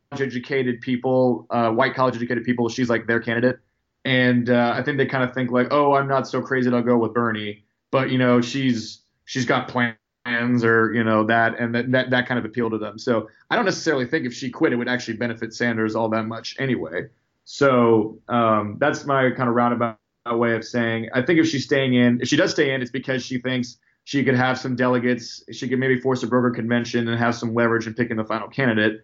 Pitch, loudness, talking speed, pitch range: 120 Hz, -21 LUFS, 230 wpm, 115-130 Hz